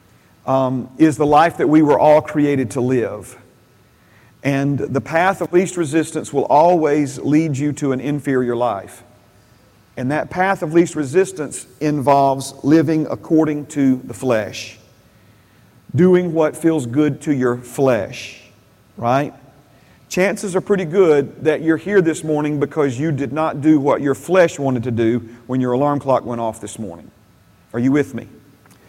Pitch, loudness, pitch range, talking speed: 140 Hz, -17 LUFS, 120-155 Hz, 160 wpm